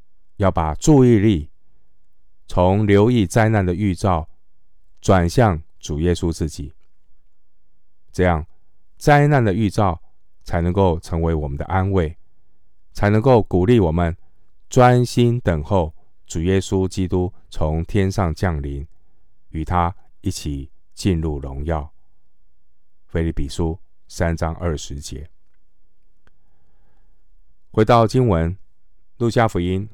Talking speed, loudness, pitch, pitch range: 165 characters per minute, -19 LUFS, 90 Hz, 80-100 Hz